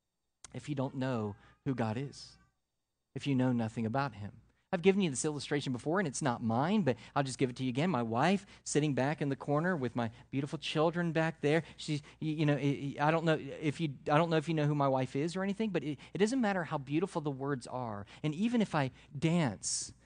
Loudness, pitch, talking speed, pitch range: -33 LUFS, 145 Hz, 235 wpm, 130-160 Hz